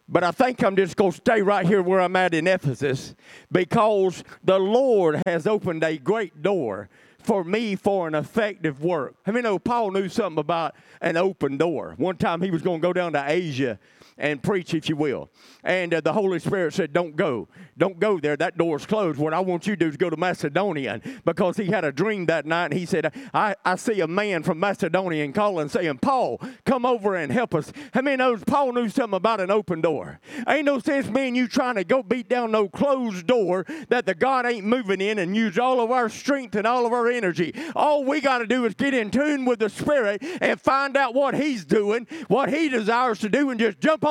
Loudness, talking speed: -23 LUFS, 230 wpm